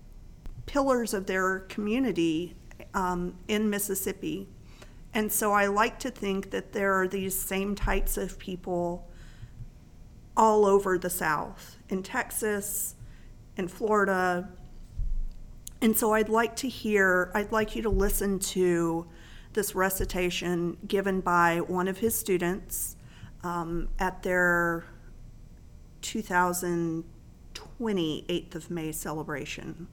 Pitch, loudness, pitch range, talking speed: 190 Hz, -28 LUFS, 175-210 Hz, 115 wpm